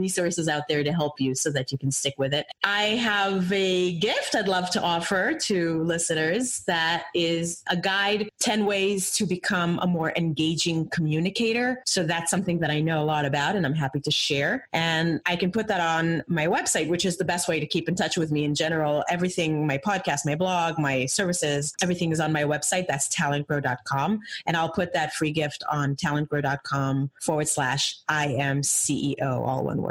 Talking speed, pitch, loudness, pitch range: 200 wpm, 165 Hz, -25 LUFS, 150-185 Hz